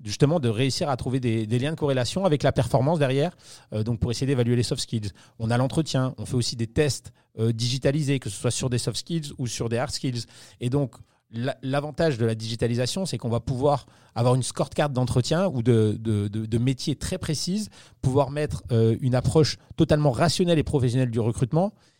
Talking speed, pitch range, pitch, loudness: 215 wpm, 120-145 Hz, 130 Hz, -25 LUFS